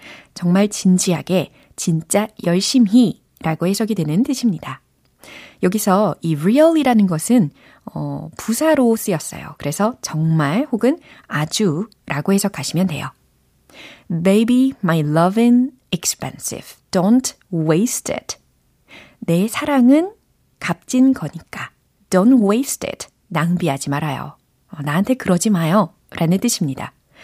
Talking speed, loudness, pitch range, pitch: 295 characters per minute, -18 LUFS, 165-235 Hz, 195 Hz